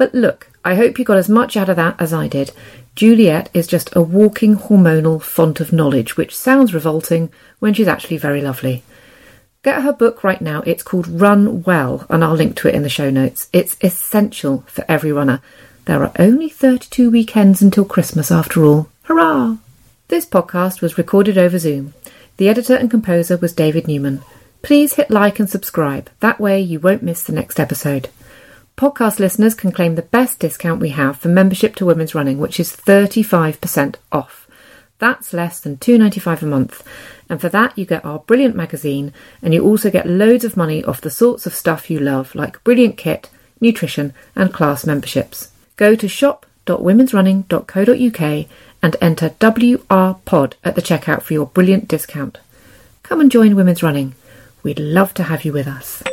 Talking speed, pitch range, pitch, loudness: 180 wpm, 155-215 Hz, 175 Hz, -15 LUFS